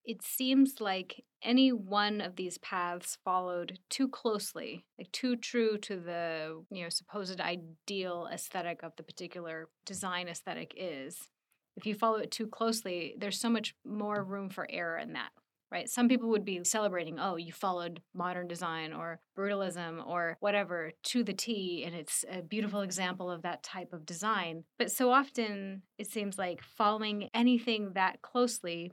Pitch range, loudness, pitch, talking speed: 175-220 Hz, -34 LUFS, 195 Hz, 165 wpm